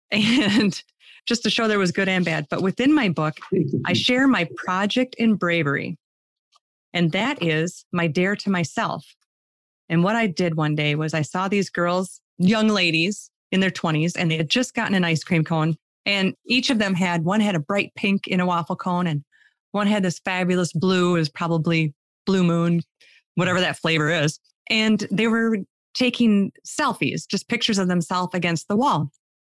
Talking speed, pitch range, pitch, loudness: 185 wpm, 165-205 Hz, 180 Hz, -22 LUFS